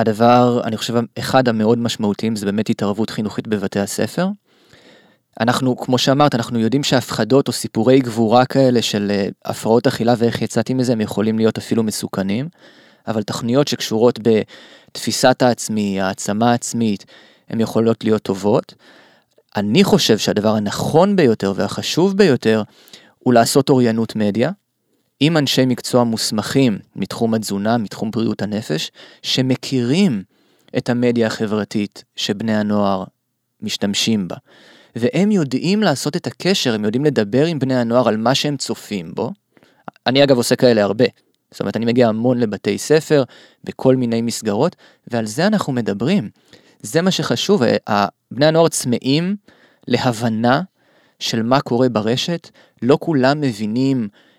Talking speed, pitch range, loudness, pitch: 135 wpm, 110-135 Hz, -17 LUFS, 120 Hz